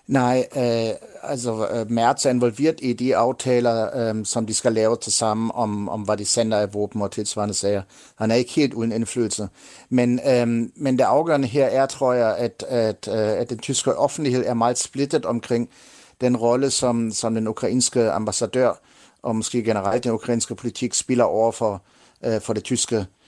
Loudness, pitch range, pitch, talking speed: -22 LUFS, 110-125 Hz, 115 Hz, 185 wpm